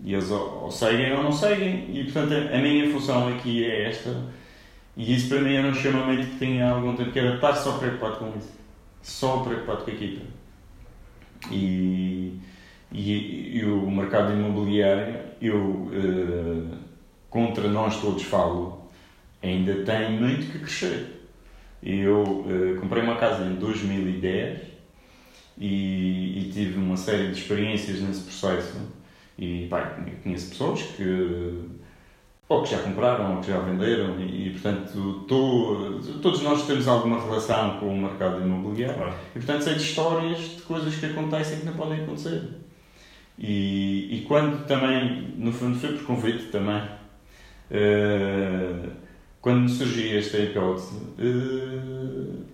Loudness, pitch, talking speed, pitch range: -26 LUFS, 105 Hz, 145 wpm, 95-125 Hz